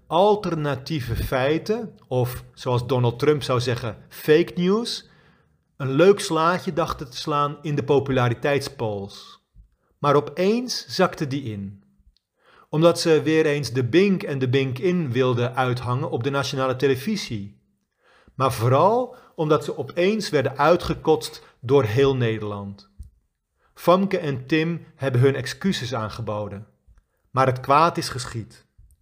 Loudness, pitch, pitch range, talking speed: -22 LUFS, 140 Hz, 120-160 Hz, 125 wpm